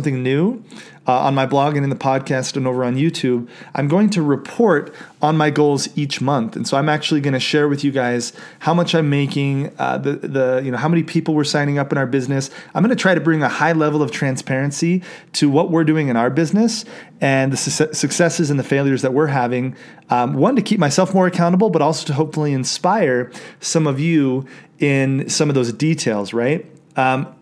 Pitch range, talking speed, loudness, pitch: 135-160 Hz, 220 wpm, -18 LUFS, 145 Hz